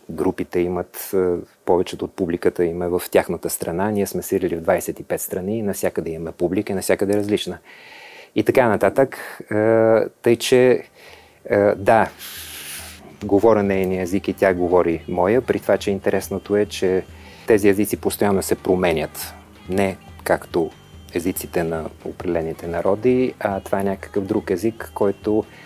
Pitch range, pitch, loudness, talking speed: 90-105 Hz, 95 Hz, -20 LUFS, 140 wpm